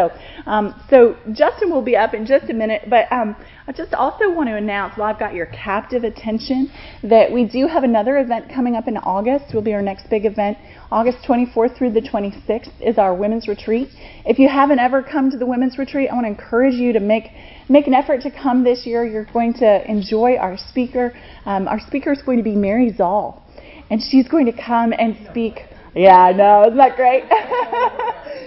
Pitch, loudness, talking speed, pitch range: 235 Hz, -17 LUFS, 210 wpm, 215-265 Hz